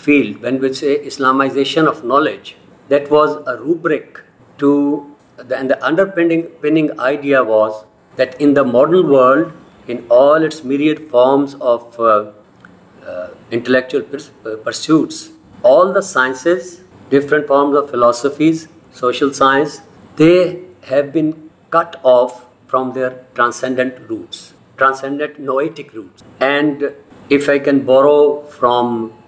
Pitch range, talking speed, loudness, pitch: 130-155 Hz, 130 wpm, -14 LUFS, 140 Hz